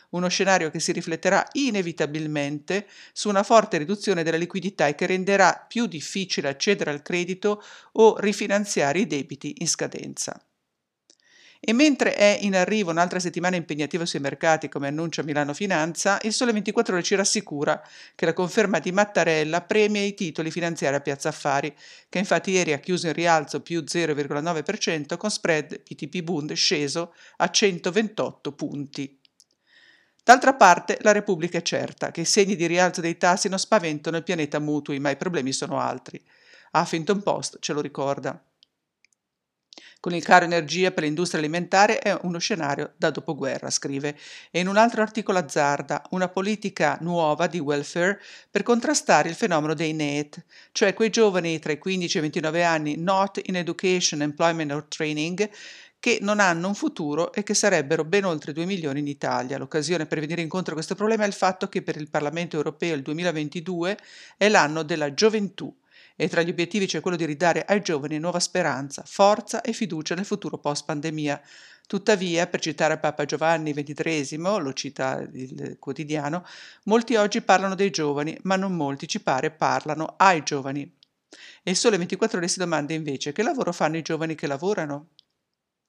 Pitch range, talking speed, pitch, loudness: 155-200 Hz, 165 wpm, 175 Hz, -24 LUFS